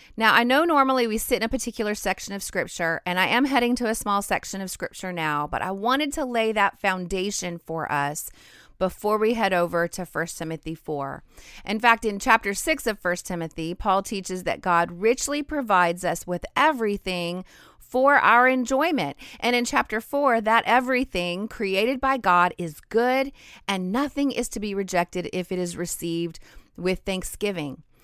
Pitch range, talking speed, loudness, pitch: 175-240 Hz, 180 wpm, -24 LUFS, 200 Hz